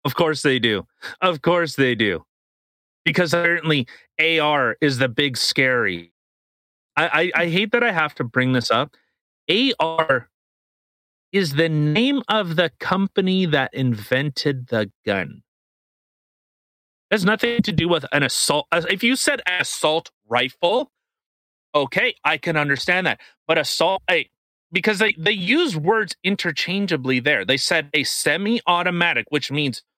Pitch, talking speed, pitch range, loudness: 165 Hz, 145 wpm, 145-195 Hz, -20 LUFS